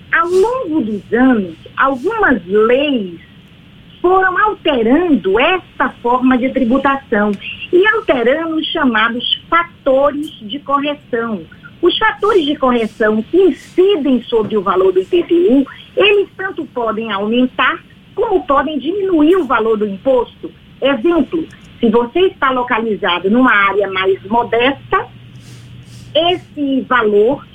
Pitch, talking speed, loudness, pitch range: 275 Hz, 115 wpm, -14 LUFS, 230-345 Hz